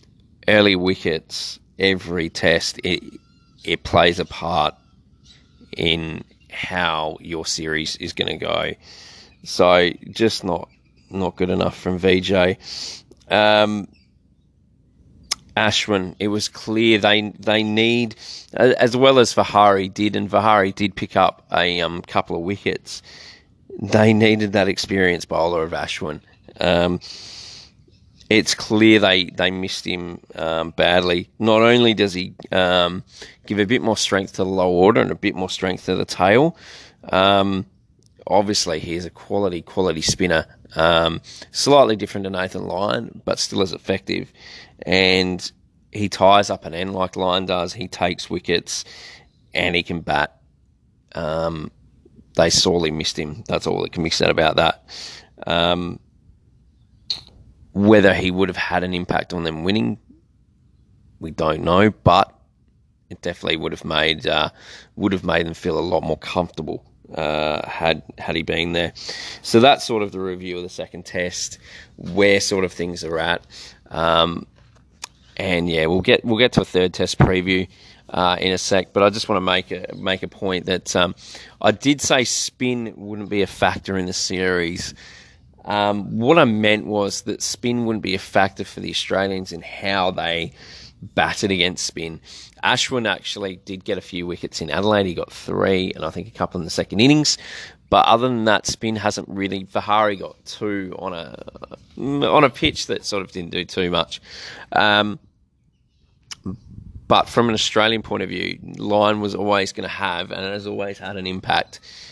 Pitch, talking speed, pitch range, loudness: 95 Hz, 165 wpm, 90-105 Hz, -19 LUFS